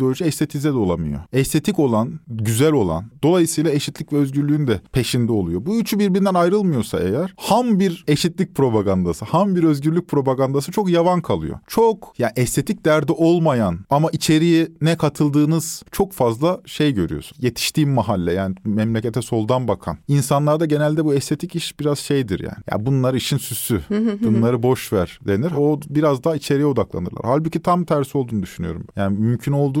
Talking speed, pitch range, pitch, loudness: 165 wpm, 120-165 Hz, 145 Hz, -19 LUFS